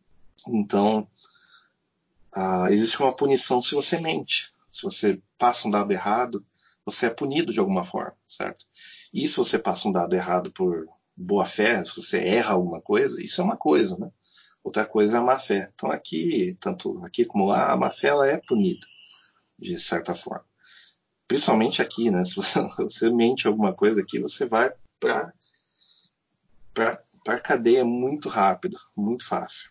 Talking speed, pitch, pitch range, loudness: 160 wpm, 120 Hz, 105-140 Hz, -24 LUFS